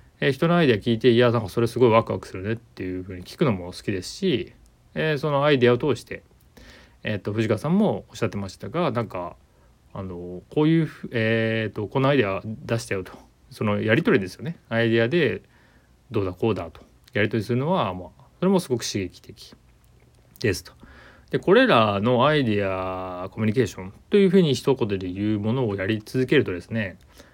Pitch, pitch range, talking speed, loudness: 110 Hz, 95-130 Hz, 395 characters per minute, -23 LUFS